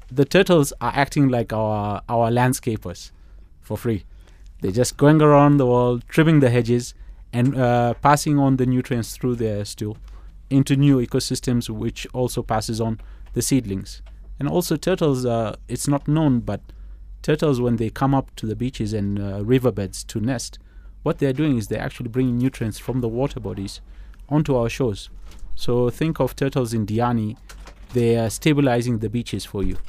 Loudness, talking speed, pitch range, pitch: -21 LUFS, 170 wpm, 105-135 Hz, 120 Hz